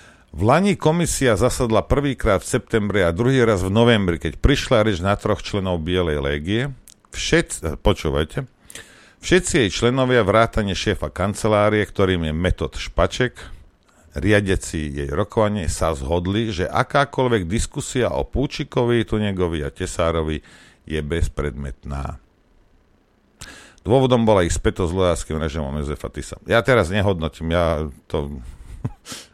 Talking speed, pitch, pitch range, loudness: 125 wpm, 95 Hz, 80-115 Hz, -20 LUFS